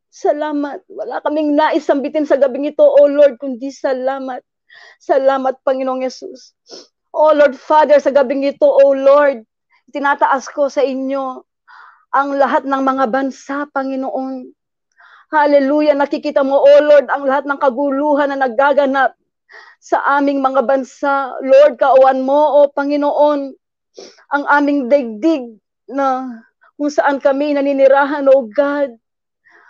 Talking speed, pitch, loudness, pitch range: 125 wpm, 280 Hz, -14 LUFS, 270-290 Hz